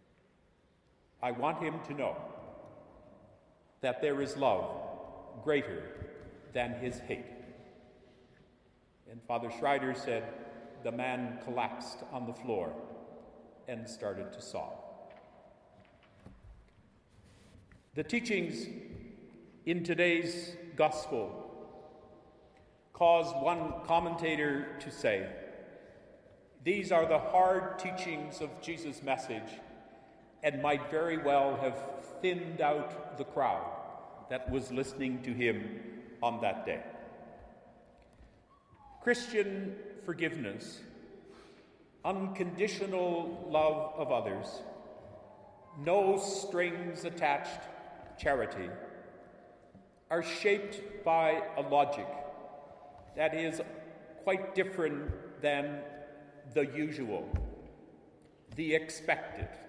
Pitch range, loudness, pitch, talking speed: 130-175 Hz, -34 LUFS, 155 Hz, 85 wpm